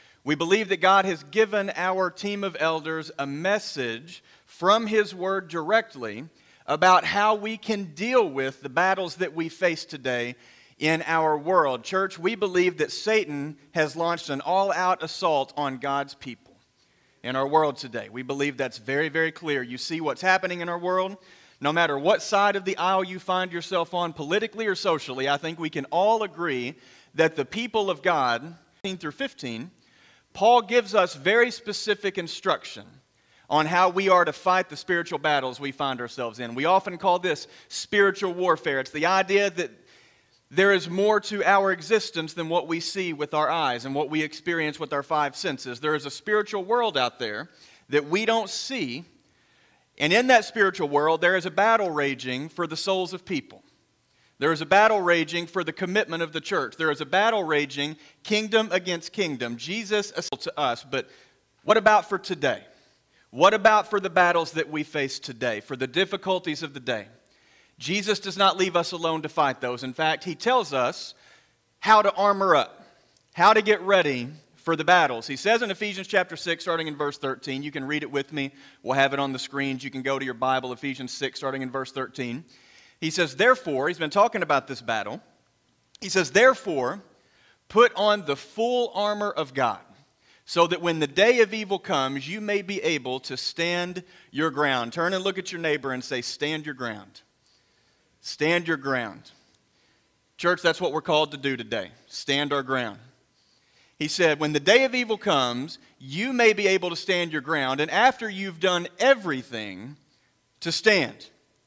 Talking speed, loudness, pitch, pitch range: 190 wpm, -24 LUFS, 165 Hz, 140-195 Hz